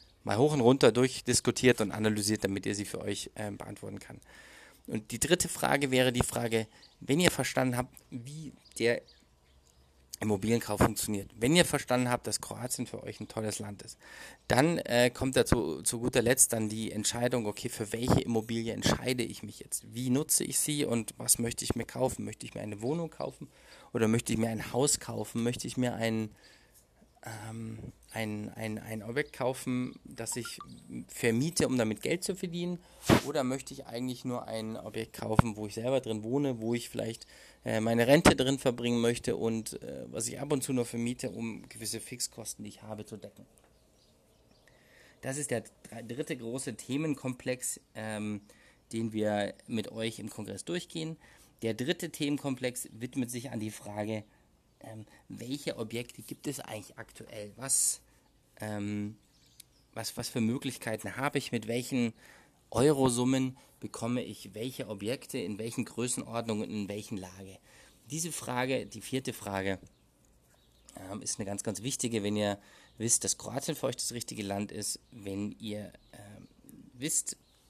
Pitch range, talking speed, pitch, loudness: 110-130 Hz, 165 wpm, 115 Hz, -32 LUFS